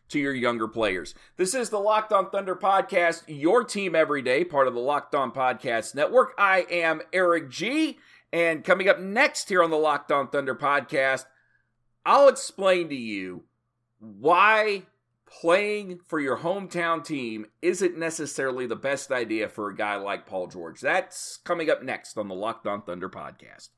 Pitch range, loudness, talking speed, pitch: 130-190 Hz, -25 LUFS, 170 wpm, 165 Hz